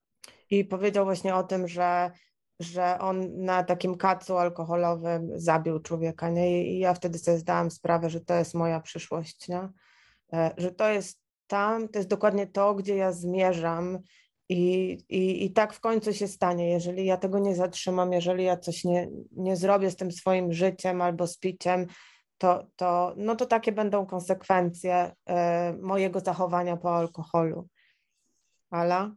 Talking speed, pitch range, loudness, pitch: 160 wpm, 175-190 Hz, -28 LUFS, 180 Hz